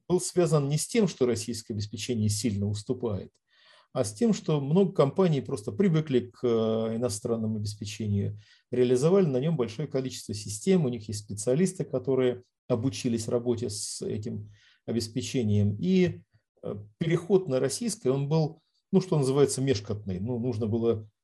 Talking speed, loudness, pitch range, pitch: 140 wpm, -28 LUFS, 110-150 Hz, 125 Hz